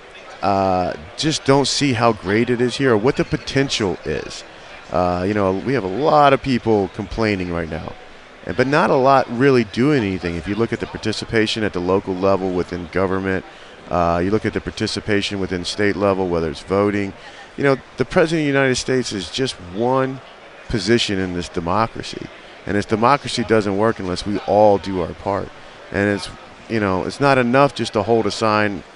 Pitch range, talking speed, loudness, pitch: 95-120 Hz, 195 wpm, -19 LUFS, 105 Hz